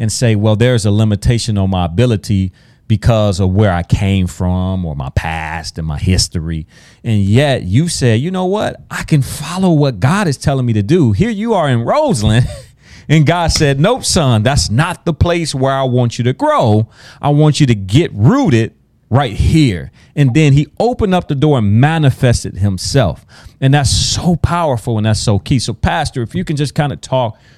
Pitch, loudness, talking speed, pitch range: 125 Hz, -13 LUFS, 200 wpm, 105-145 Hz